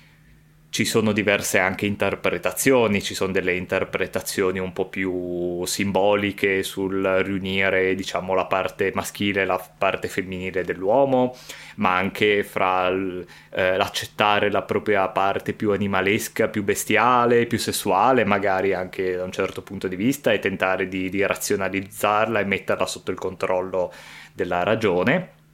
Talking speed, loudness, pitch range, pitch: 135 wpm, -22 LUFS, 95-105 Hz, 95 Hz